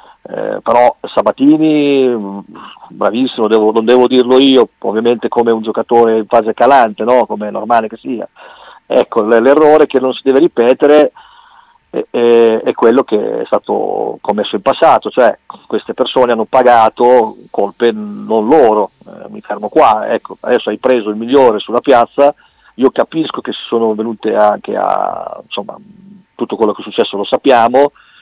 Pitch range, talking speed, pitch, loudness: 115-150 Hz, 160 wpm, 125 Hz, -11 LUFS